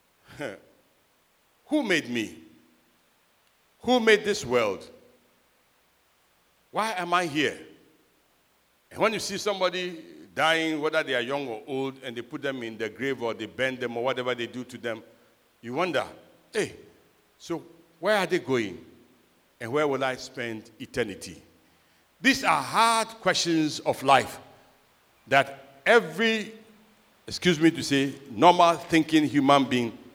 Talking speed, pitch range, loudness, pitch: 140 wpm, 130-185 Hz, -26 LUFS, 155 Hz